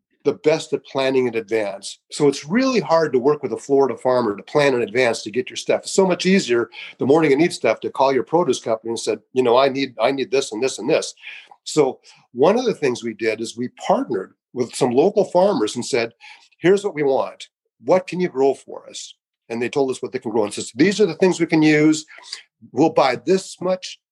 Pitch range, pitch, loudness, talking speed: 120-185 Hz, 140 Hz, -19 LUFS, 245 wpm